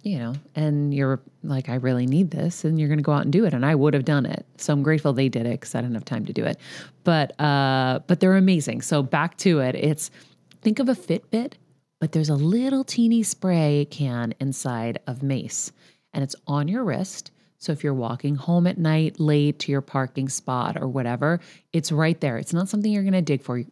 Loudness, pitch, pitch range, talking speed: -23 LUFS, 150 Hz, 135-175 Hz, 235 wpm